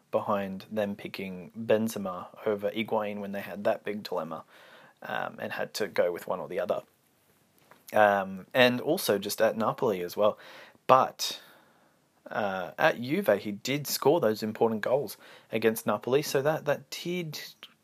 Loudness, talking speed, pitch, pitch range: -29 LUFS, 155 wpm, 110 Hz, 100-125 Hz